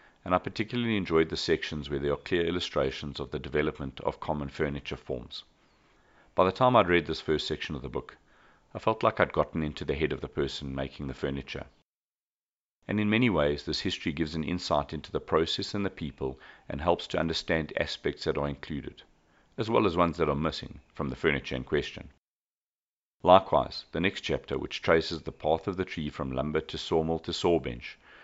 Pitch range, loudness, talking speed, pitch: 70-90 Hz, -30 LUFS, 200 wpm, 80 Hz